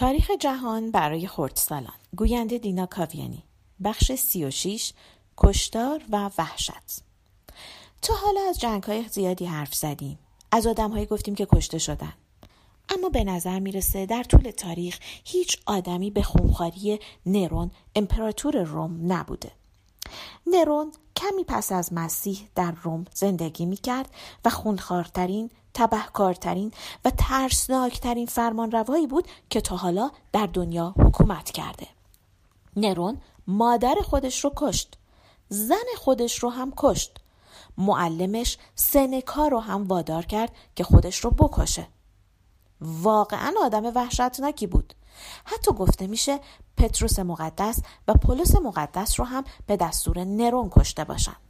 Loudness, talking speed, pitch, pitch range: -25 LUFS, 120 wpm, 210 Hz, 175-250 Hz